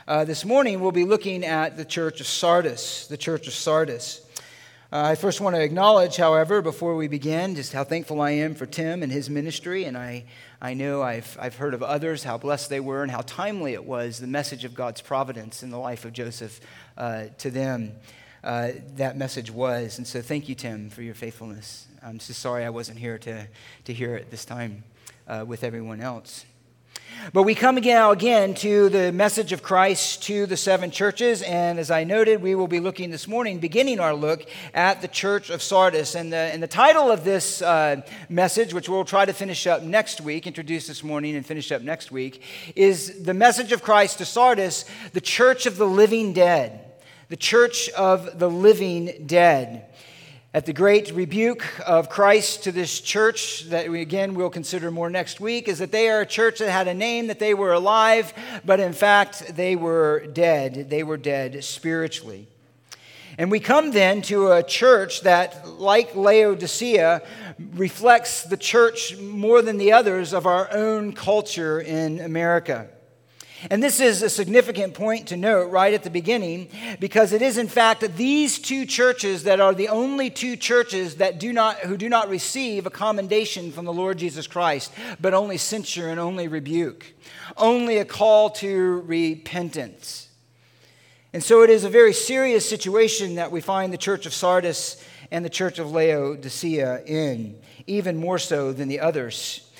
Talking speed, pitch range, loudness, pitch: 190 wpm, 145-205 Hz, -21 LUFS, 175 Hz